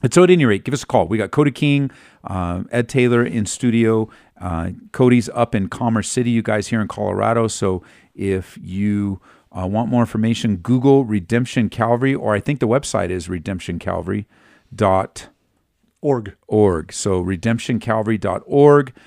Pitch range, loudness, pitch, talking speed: 95-120 Hz, -18 LUFS, 110 Hz, 150 wpm